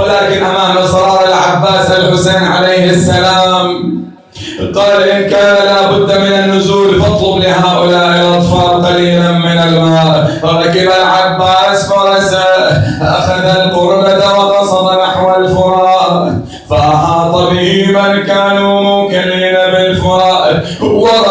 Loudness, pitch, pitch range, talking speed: -8 LUFS, 185 Hz, 175-195 Hz, 85 wpm